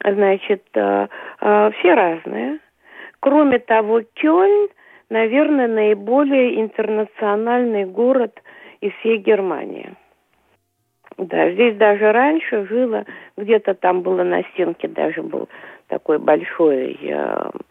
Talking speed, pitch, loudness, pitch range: 90 wpm, 220 Hz, -18 LUFS, 205-255 Hz